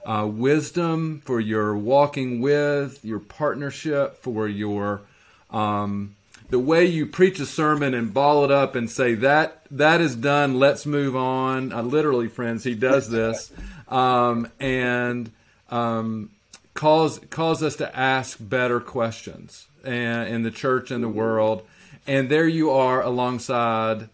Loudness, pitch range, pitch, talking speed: -22 LUFS, 115-145 Hz, 130 Hz, 145 wpm